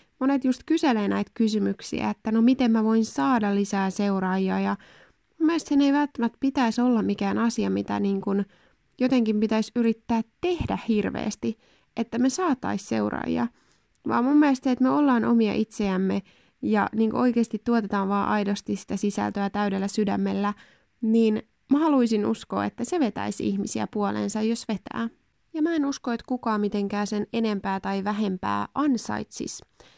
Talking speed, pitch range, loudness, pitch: 155 wpm, 200-245 Hz, -25 LUFS, 220 Hz